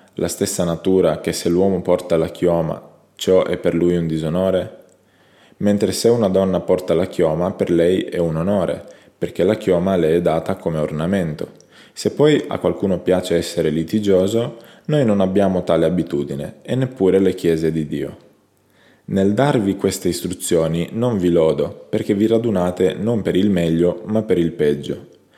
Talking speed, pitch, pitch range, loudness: 170 wpm, 90 Hz, 85-100 Hz, -18 LUFS